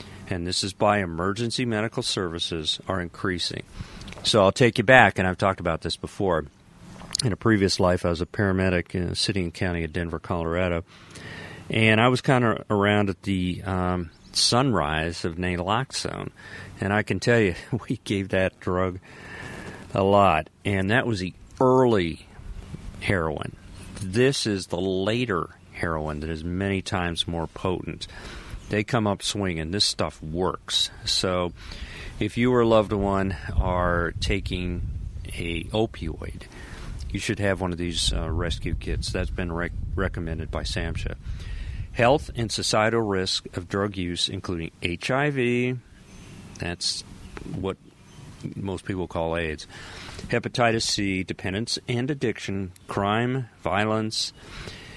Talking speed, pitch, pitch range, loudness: 145 wpm, 95 Hz, 85-110 Hz, -25 LUFS